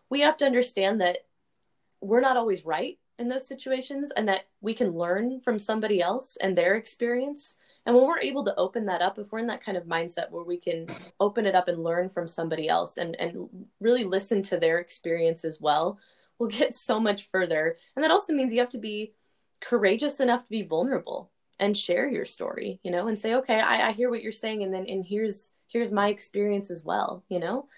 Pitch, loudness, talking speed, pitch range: 210 Hz, -27 LUFS, 220 wpm, 180-245 Hz